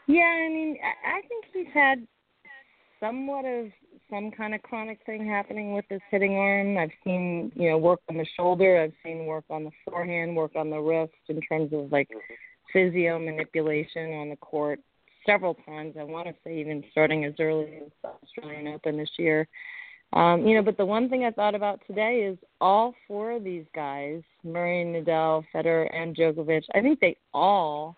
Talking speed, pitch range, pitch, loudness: 185 wpm, 155-215 Hz, 175 Hz, -26 LUFS